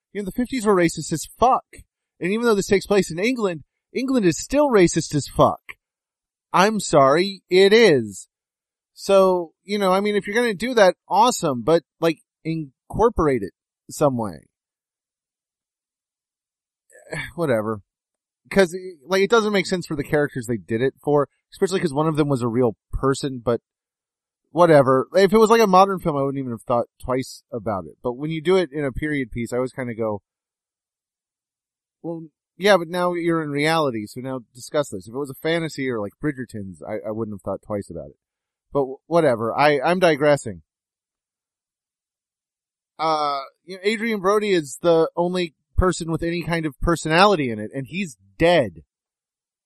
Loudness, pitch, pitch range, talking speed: -21 LUFS, 160 Hz, 130-185 Hz, 180 wpm